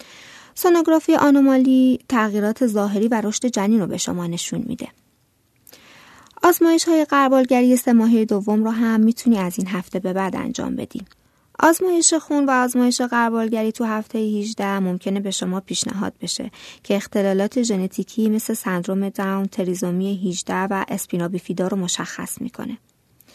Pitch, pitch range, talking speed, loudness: 220 Hz, 195-250 Hz, 140 wpm, -20 LUFS